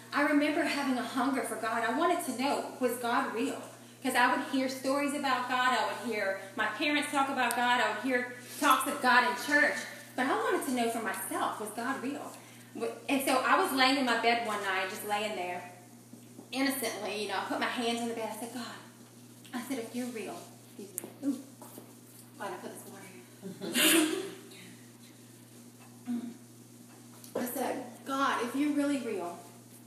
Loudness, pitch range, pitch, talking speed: -31 LUFS, 230-275 Hz, 250 Hz, 180 wpm